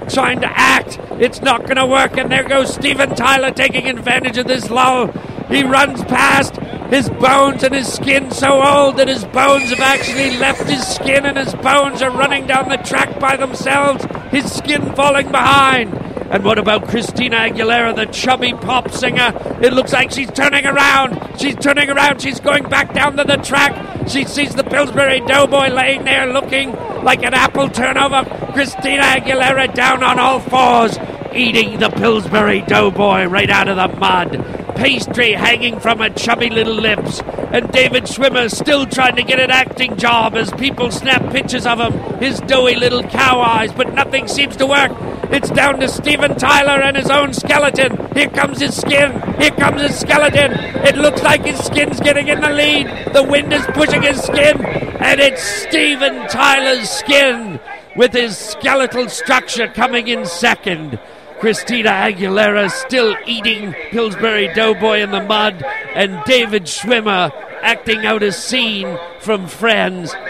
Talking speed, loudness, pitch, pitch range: 165 wpm, -13 LUFS, 255 Hz, 225-275 Hz